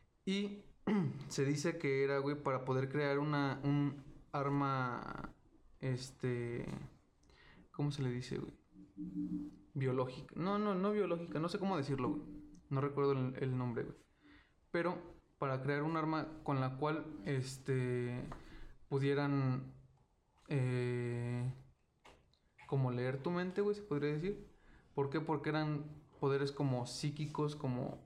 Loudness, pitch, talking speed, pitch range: -39 LUFS, 140 Hz, 130 wpm, 130-155 Hz